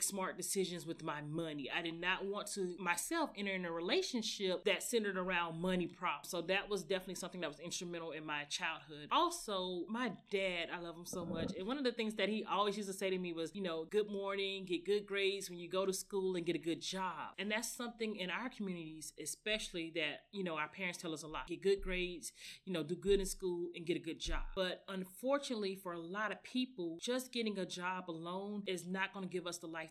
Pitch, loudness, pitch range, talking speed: 185 Hz, -40 LUFS, 170-200 Hz, 240 wpm